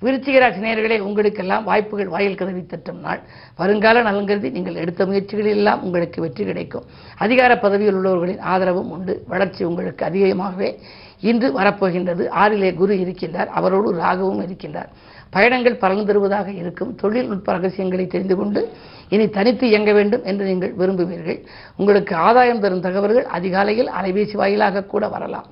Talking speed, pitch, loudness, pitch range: 130 wpm, 195 Hz, -18 LUFS, 185-210 Hz